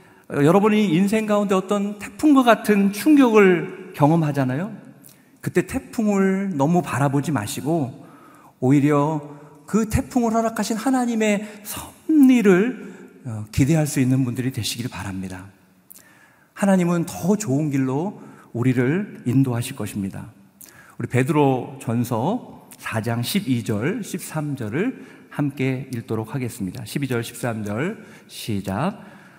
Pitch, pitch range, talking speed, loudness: 150 Hz, 125-200 Hz, 245 characters per minute, -21 LUFS